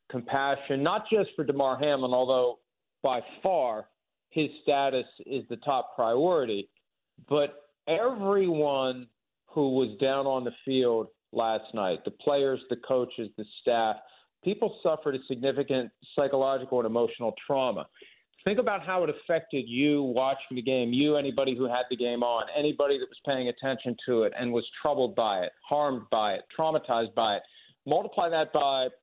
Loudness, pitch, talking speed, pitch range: -28 LUFS, 135 Hz, 155 wpm, 125-145 Hz